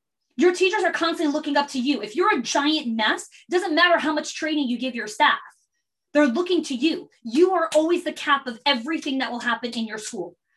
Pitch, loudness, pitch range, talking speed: 300 Hz, -22 LUFS, 260-335 Hz, 225 wpm